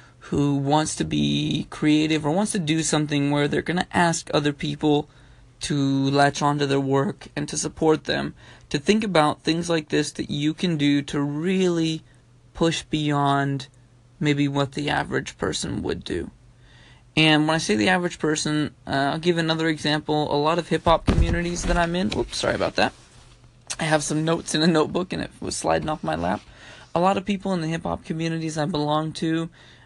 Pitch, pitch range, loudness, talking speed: 150 Hz, 140-165 Hz, -23 LUFS, 195 wpm